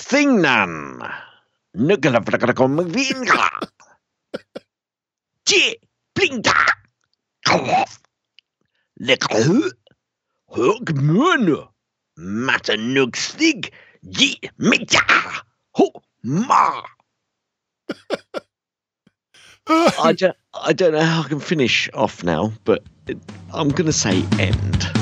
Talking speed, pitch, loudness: 80 wpm, 160 Hz, -18 LUFS